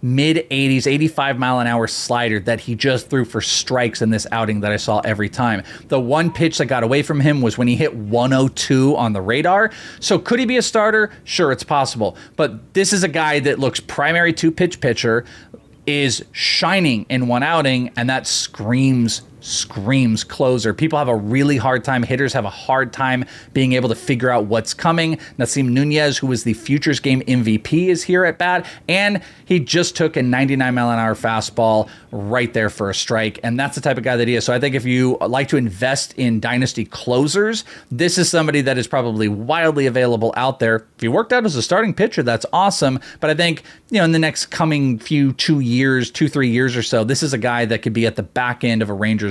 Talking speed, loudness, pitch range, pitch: 225 wpm, -17 LUFS, 115-150 Hz, 130 Hz